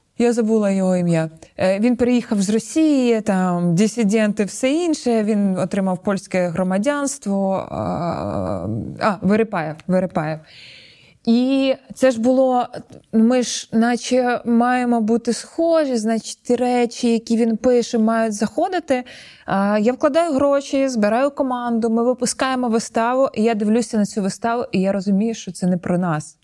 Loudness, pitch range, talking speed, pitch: -19 LUFS, 190-245 Hz, 130 wpm, 225 Hz